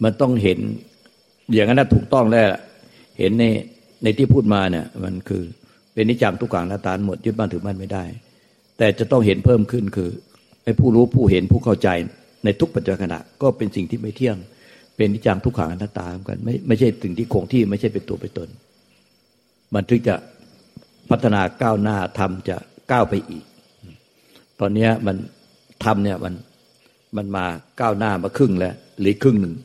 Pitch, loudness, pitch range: 105 Hz, -20 LUFS, 95-115 Hz